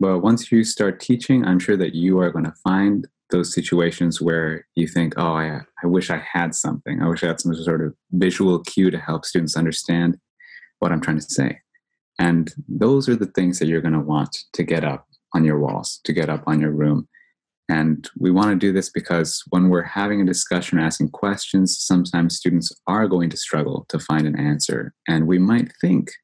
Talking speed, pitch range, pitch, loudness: 215 wpm, 80-95 Hz, 85 Hz, -20 LUFS